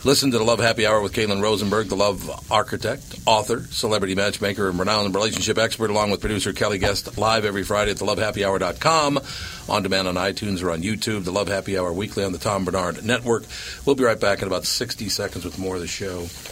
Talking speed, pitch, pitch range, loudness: 215 wpm, 100 Hz, 95-110 Hz, -22 LUFS